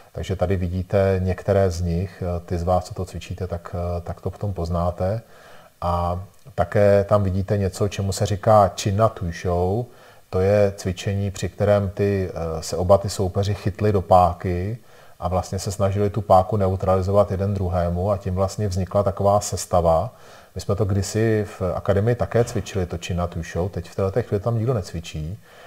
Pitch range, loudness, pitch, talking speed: 90-105 Hz, -22 LUFS, 95 Hz, 175 wpm